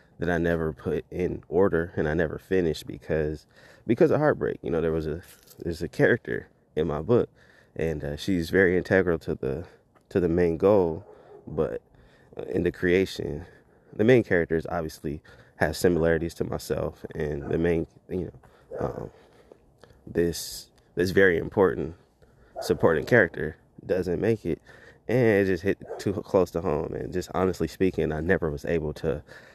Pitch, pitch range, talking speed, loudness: 85 Hz, 80-90 Hz, 160 wpm, -26 LUFS